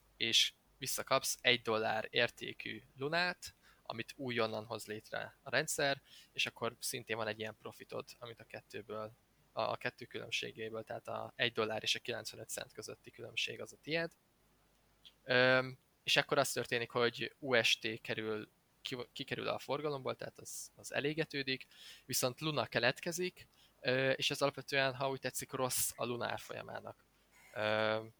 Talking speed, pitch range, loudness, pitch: 145 wpm, 110-140 Hz, -37 LUFS, 125 Hz